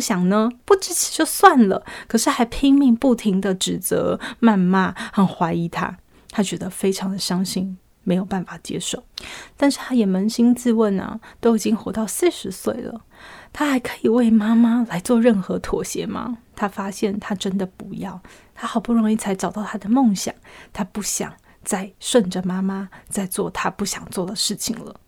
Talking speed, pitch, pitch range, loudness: 260 characters per minute, 215 Hz, 195-235 Hz, -20 LUFS